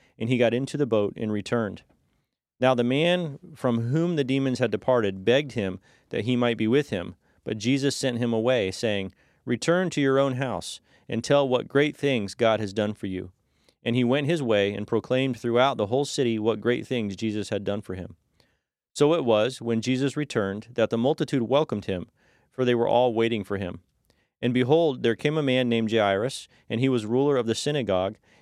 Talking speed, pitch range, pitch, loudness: 205 wpm, 110-135 Hz, 120 Hz, -25 LUFS